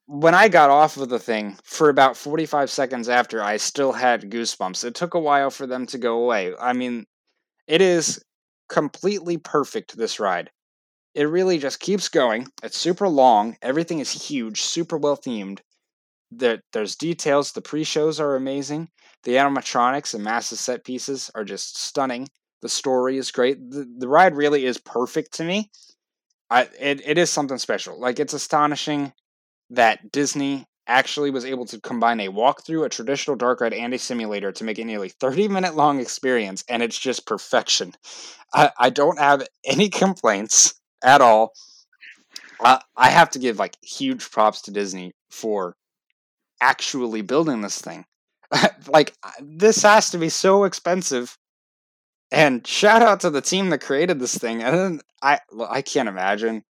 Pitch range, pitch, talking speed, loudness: 120-165 Hz, 140 Hz, 160 wpm, -20 LUFS